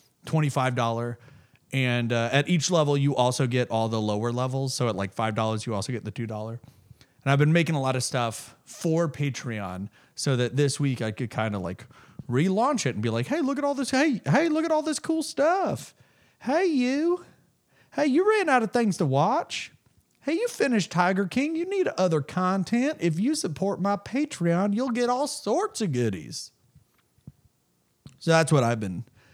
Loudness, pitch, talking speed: -26 LUFS, 145 Hz, 190 wpm